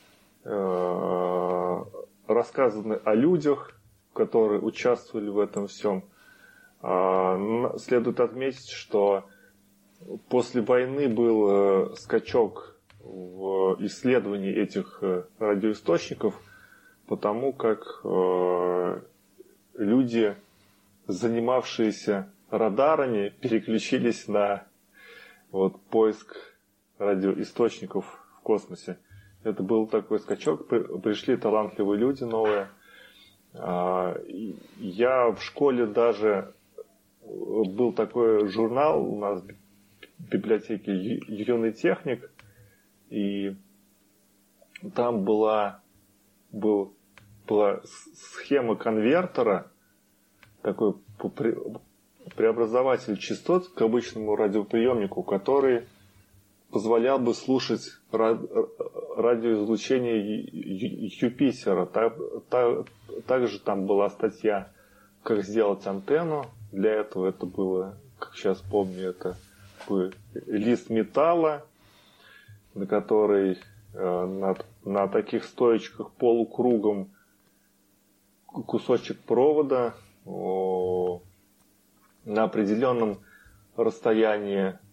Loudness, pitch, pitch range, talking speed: -26 LUFS, 105 Hz, 100-115 Hz, 70 wpm